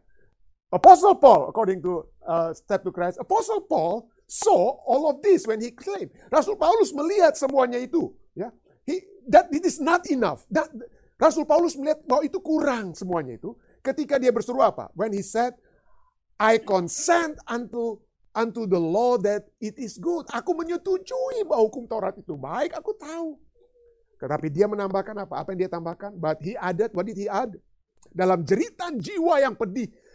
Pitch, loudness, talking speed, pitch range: 255 Hz, -23 LUFS, 165 wpm, 205-340 Hz